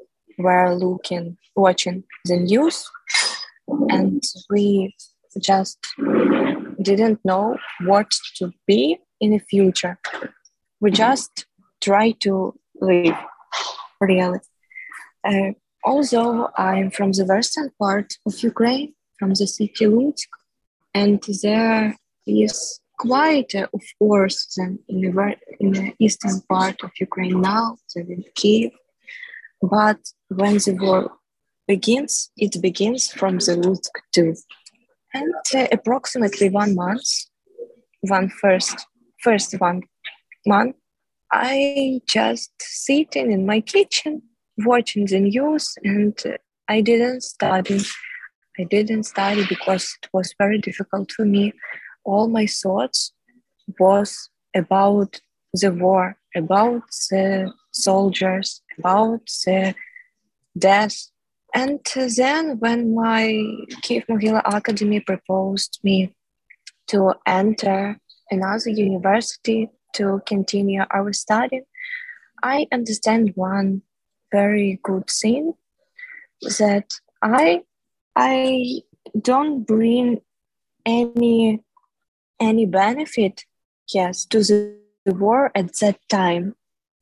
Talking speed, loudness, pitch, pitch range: 105 wpm, -20 LUFS, 205 Hz, 195-235 Hz